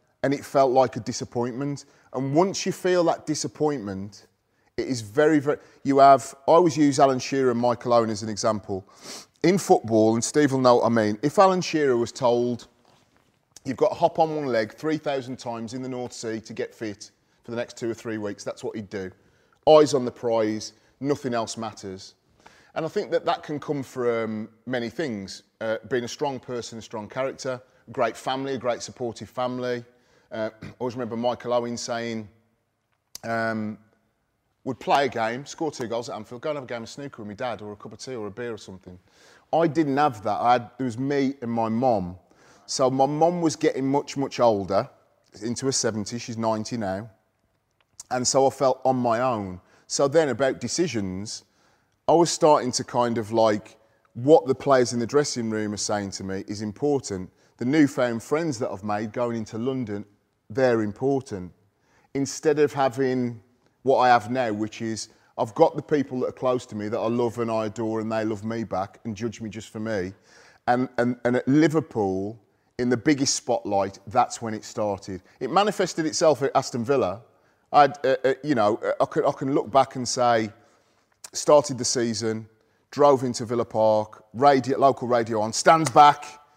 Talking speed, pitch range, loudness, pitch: 200 wpm, 110-135 Hz, -24 LUFS, 120 Hz